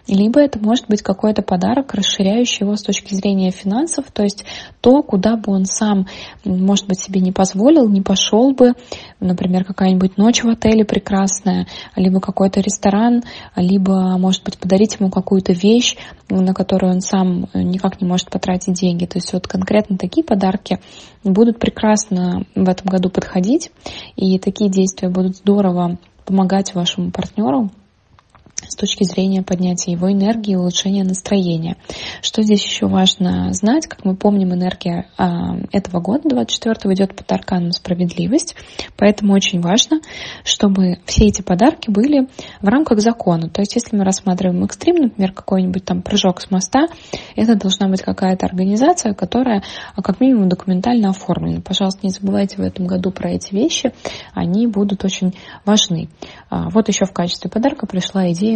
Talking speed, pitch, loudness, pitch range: 155 wpm, 195 Hz, -16 LUFS, 185-215 Hz